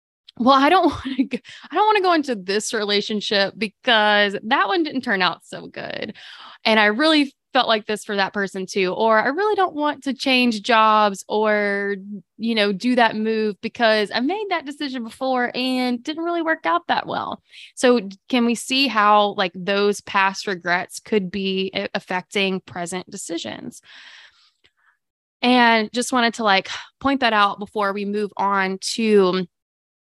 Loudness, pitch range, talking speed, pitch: -20 LUFS, 200-255 Hz, 170 wpm, 220 Hz